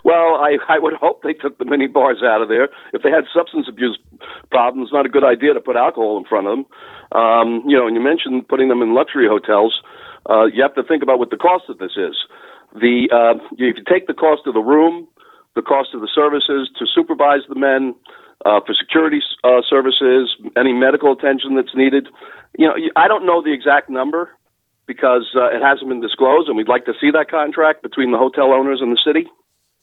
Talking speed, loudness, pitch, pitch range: 225 wpm, -15 LUFS, 140 Hz, 130-160 Hz